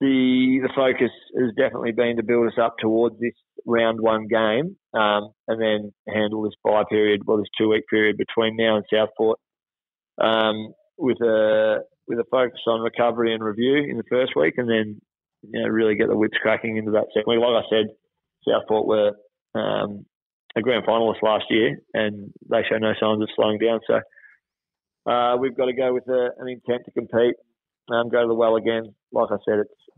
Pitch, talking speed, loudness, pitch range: 115 Hz, 200 wpm, -22 LUFS, 110-120 Hz